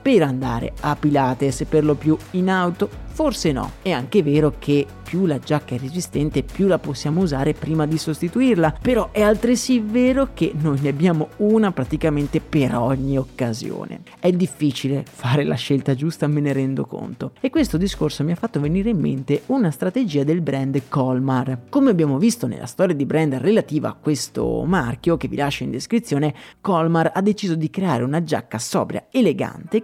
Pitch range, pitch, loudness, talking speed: 140-185 Hz, 155 Hz, -20 LUFS, 180 wpm